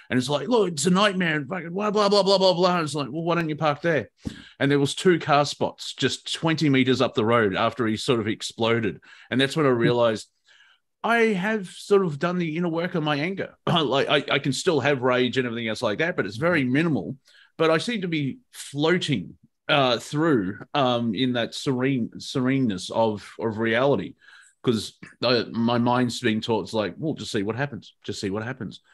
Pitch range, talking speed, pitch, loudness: 120-170 Hz, 220 wpm, 145 Hz, -23 LUFS